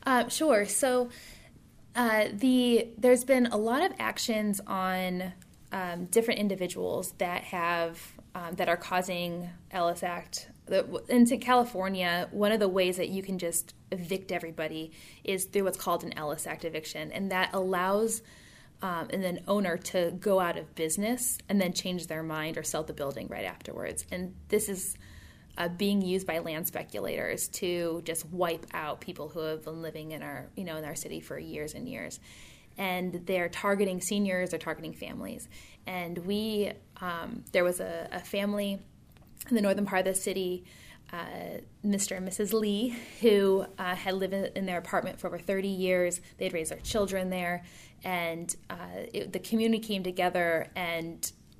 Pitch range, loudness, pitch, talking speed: 175-205 Hz, -31 LUFS, 185 Hz, 170 wpm